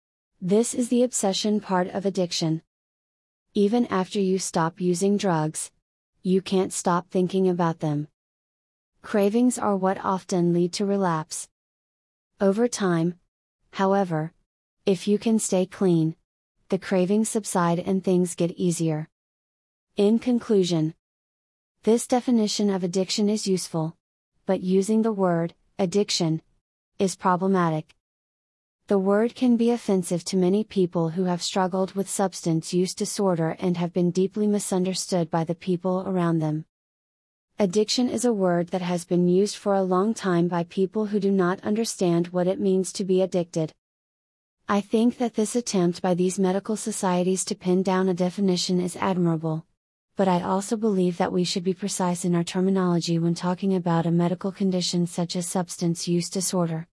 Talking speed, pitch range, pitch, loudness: 150 wpm, 175-200 Hz, 185 Hz, -24 LUFS